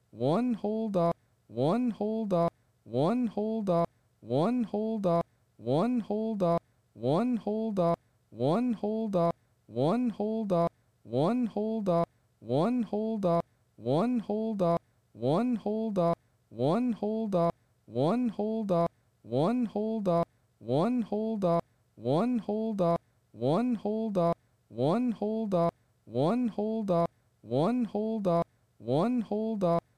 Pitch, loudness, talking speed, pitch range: 175 Hz, -30 LUFS, 140 wpm, 130-220 Hz